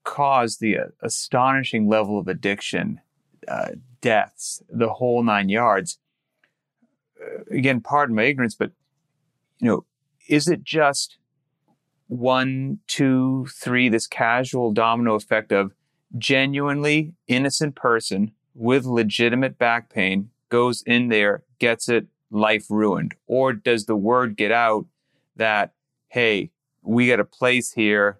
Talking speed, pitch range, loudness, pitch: 125 wpm, 110-140 Hz, -21 LUFS, 120 Hz